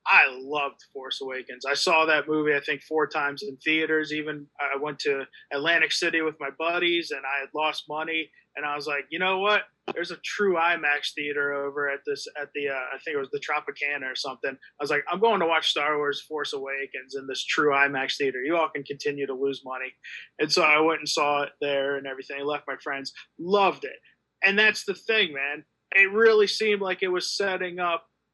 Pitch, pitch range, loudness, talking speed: 150 Hz, 140-175 Hz, -25 LUFS, 225 wpm